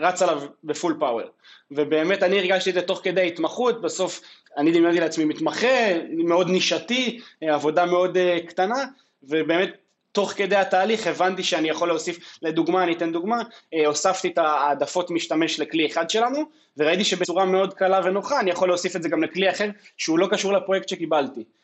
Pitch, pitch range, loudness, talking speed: 180 Hz, 165-195 Hz, -22 LUFS, 165 wpm